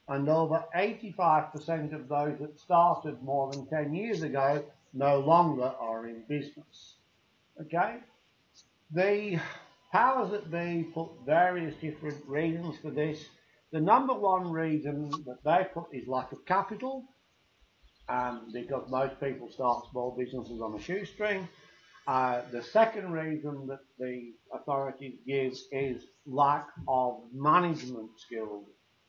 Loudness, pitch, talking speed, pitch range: -31 LUFS, 150 Hz, 130 wpm, 130-170 Hz